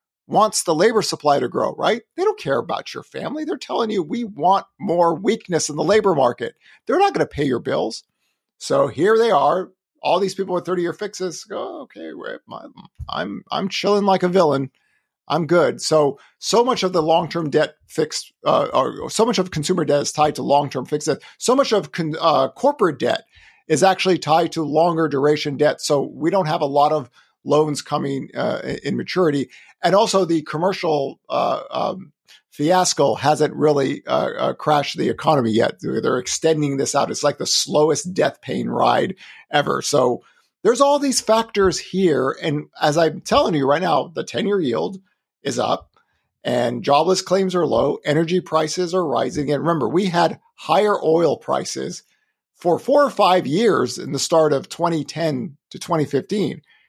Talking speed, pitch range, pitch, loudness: 180 wpm, 150-195 Hz, 170 Hz, -19 LUFS